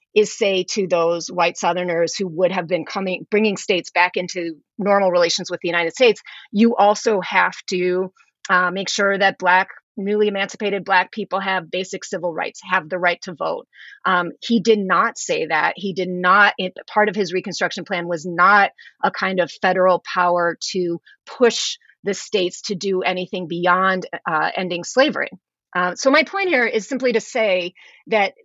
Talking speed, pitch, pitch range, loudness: 180 wpm, 185 Hz, 180-210 Hz, -19 LUFS